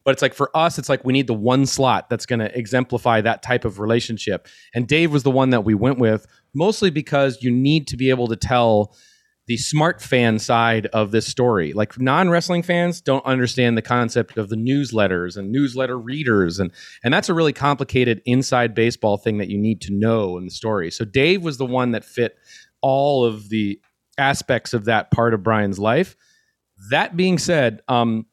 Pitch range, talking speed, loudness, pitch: 110-140 Hz, 205 wpm, -19 LUFS, 125 Hz